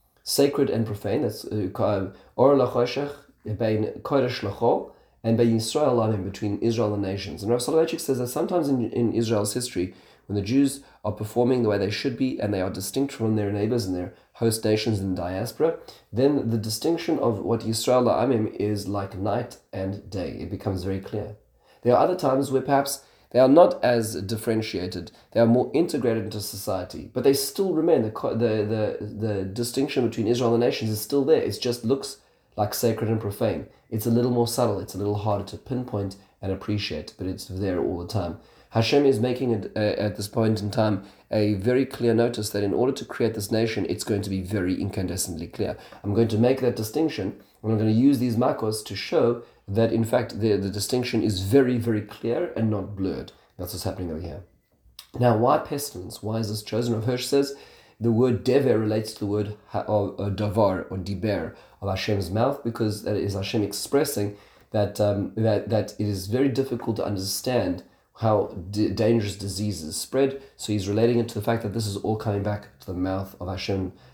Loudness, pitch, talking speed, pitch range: -25 LUFS, 110 Hz, 195 wpm, 100-120 Hz